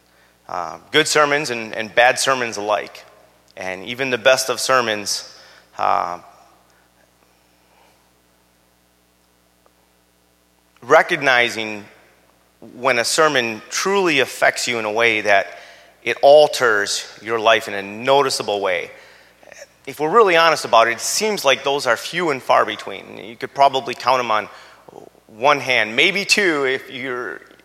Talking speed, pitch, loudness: 130 wpm, 110 Hz, -17 LUFS